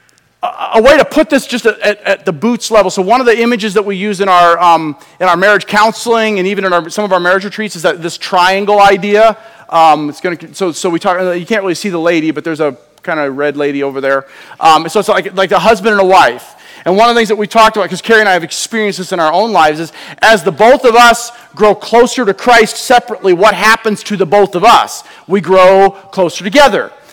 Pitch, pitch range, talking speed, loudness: 195 Hz, 175-220 Hz, 255 wpm, -10 LUFS